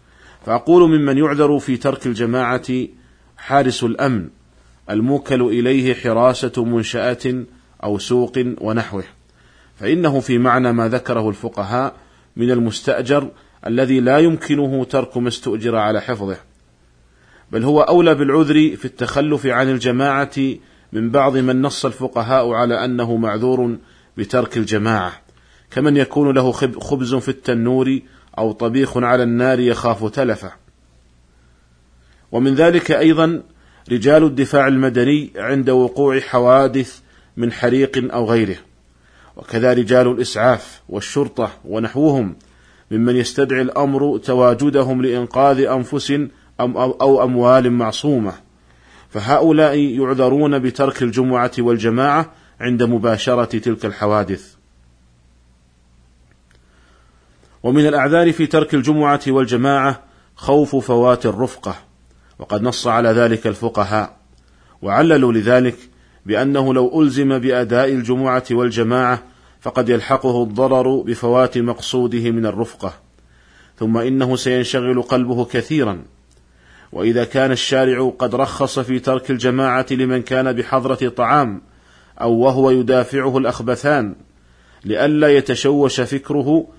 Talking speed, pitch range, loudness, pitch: 105 wpm, 110-135 Hz, -16 LUFS, 125 Hz